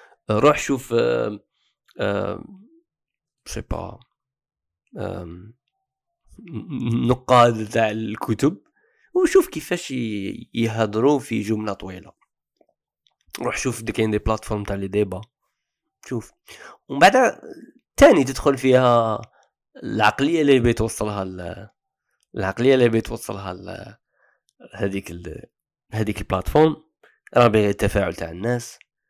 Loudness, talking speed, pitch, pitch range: -21 LUFS, 80 wpm, 115 Hz, 105-135 Hz